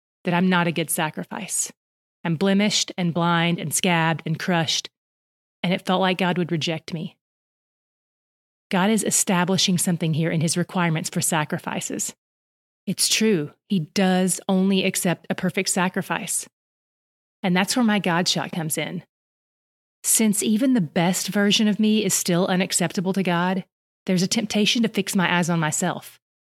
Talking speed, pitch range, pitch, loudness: 160 wpm, 170-195 Hz, 180 Hz, -22 LUFS